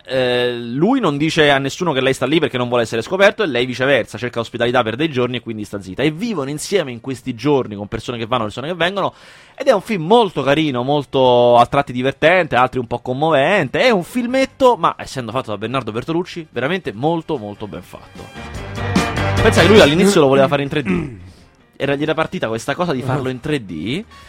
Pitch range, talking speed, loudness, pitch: 120-155 Hz, 215 wpm, -17 LUFS, 130 Hz